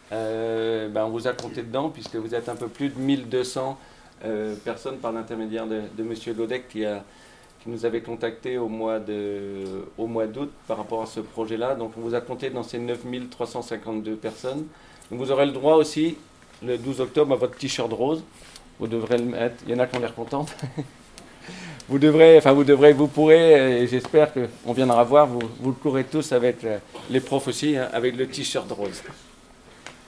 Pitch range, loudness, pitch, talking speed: 115-135 Hz, -23 LUFS, 120 Hz, 200 wpm